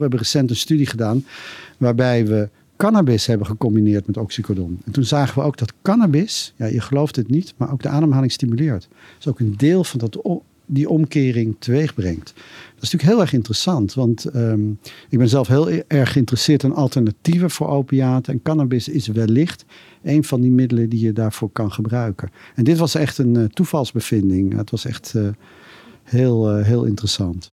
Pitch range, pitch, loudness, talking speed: 110-145 Hz, 125 Hz, -18 LUFS, 185 wpm